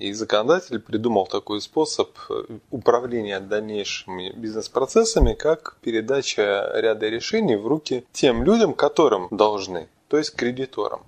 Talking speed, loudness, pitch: 115 wpm, -22 LUFS, 130 Hz